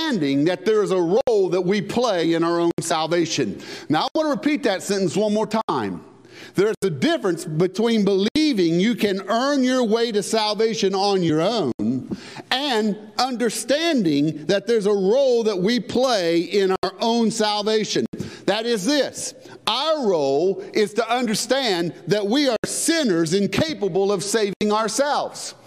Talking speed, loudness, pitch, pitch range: 155 wpm, -21 LUFS, 210 Hz, 190-240 Hz